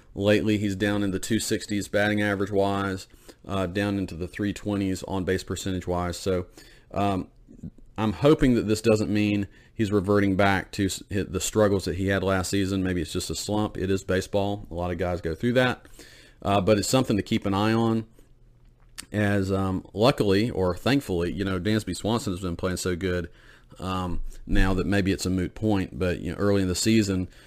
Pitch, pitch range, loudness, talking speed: 100 Hz, 95-105 Hz, -25 LUFS, 190 wpm